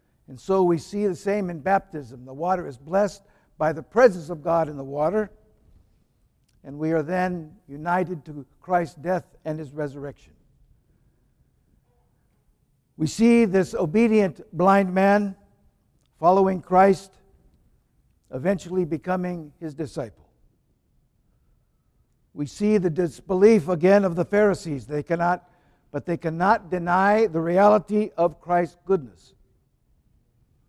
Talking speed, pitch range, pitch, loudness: 120 wpm, 150-195 Hz, 175 Hz, -23 LUFS